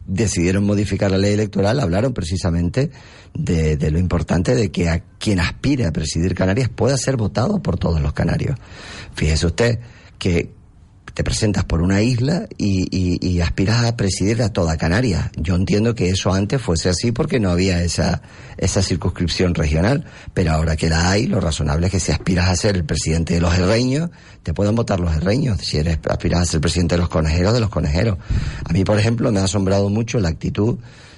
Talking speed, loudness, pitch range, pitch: 195 wpm, -19 LUFS, 85-110 Hz, 95 Hz